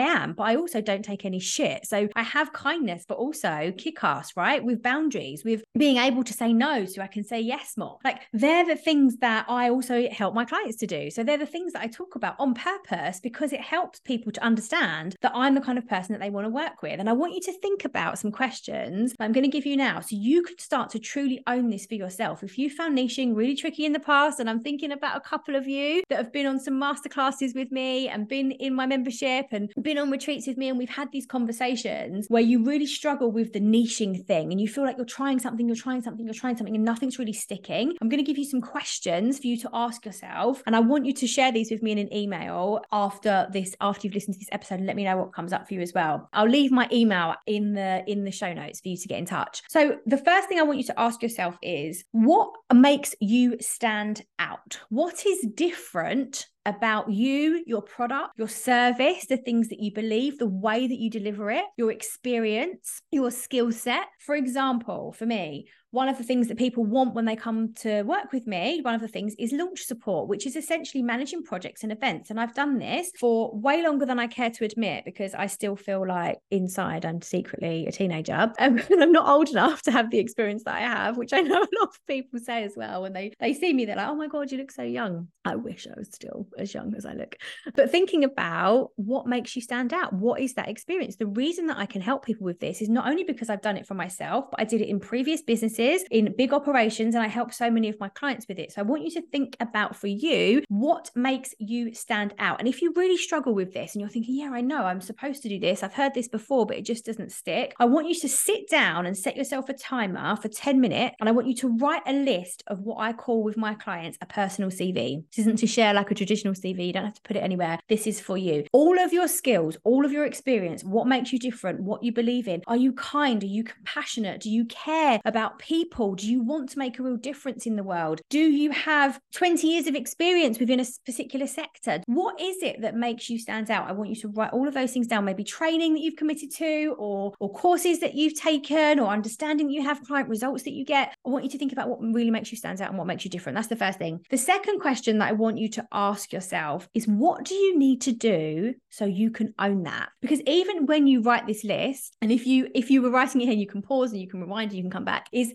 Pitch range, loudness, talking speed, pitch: 215-280 Hz, -26 LUFS, 260 wpm, 240 Hz